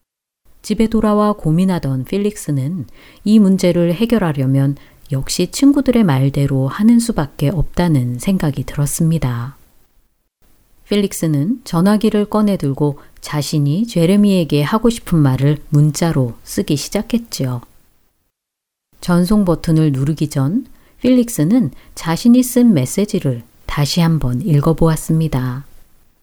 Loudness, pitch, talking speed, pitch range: -16 LUFS, 160 Hz, 260 characters per minute, 140-205 Hz